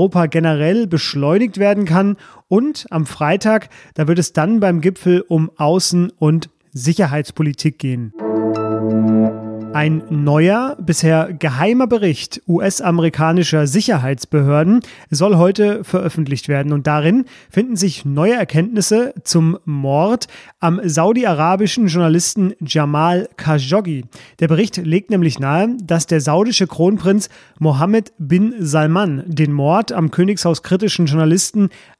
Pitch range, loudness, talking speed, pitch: 155-195 Hz, -16 LUFS, 115 wpm, 170 Hz